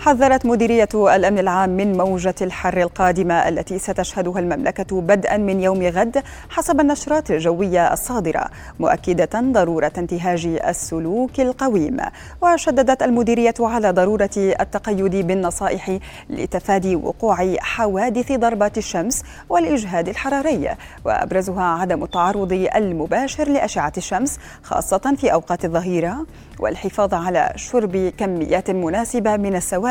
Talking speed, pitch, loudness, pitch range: 110 wpm, 195 Hz, -19 LUFS, 180-235 Hz